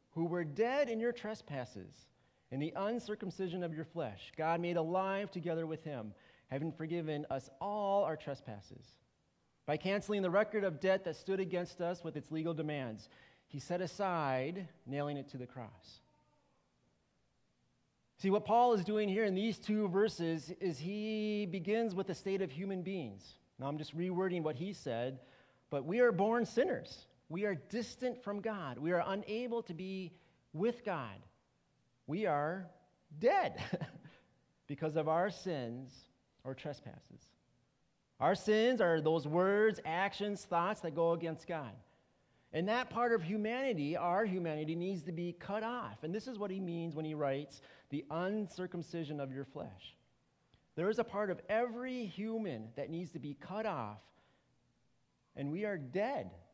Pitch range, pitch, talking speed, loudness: 145-205 Hz, 175 Hz, 160 wpm, -37 LUFS